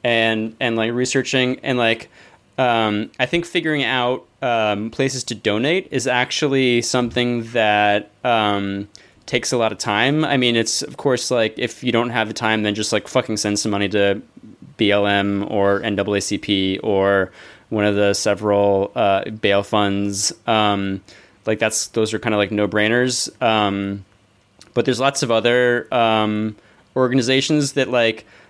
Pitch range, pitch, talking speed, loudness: 100-125 Hz, 110 Hz, 160 wpm, -19 LUFS